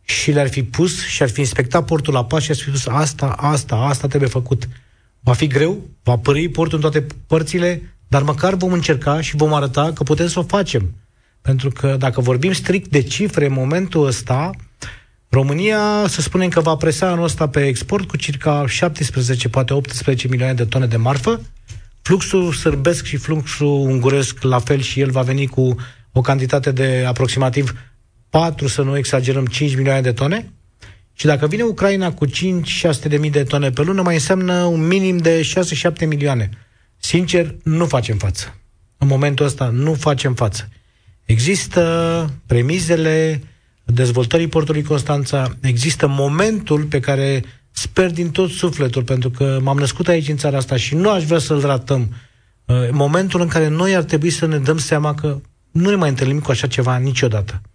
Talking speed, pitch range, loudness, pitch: 175 wpm, 130-160 Hz, -17 LUFS, 140 Hz